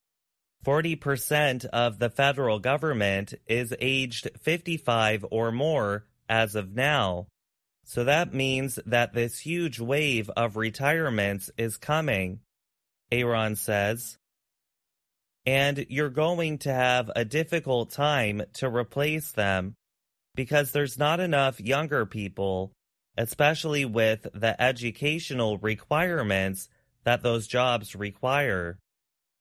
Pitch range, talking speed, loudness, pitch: 110-145 Hz, 105 wpm, -27 LUFS, 120 Hz